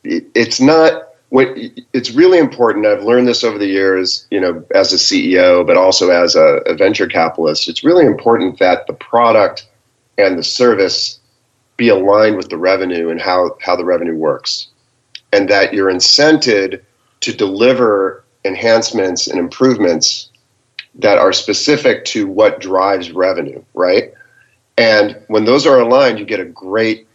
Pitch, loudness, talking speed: 120 Hz, -12 LUFS, 155 wpm